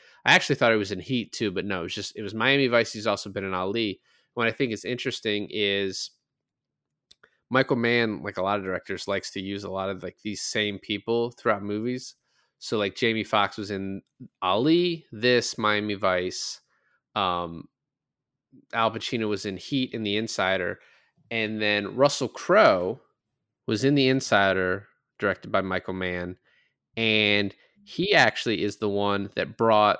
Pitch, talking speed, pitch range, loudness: 105 Hz, 170 wpm, 100-115 Hz, -25 LUFS